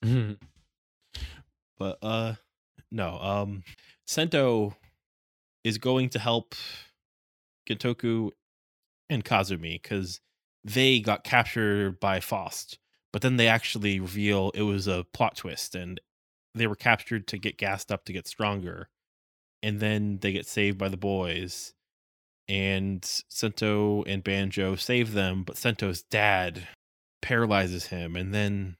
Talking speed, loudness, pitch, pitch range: 125 wpm, -28 LUFS, 100 Hz, 90-110 Hz